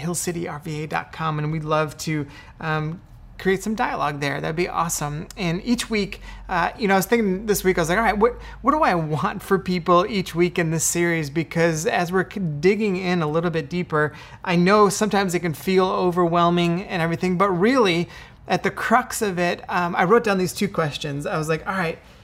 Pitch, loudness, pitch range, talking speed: 175 Hz, -22 LUFS, 160-195 Hz, 210 wpm